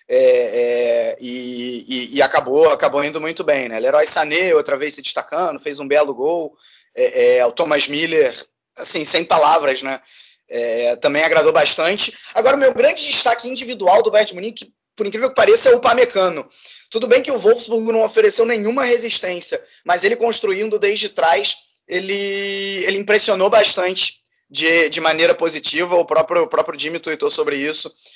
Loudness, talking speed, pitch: -16 LUFS, 170 wpm, 215 Hz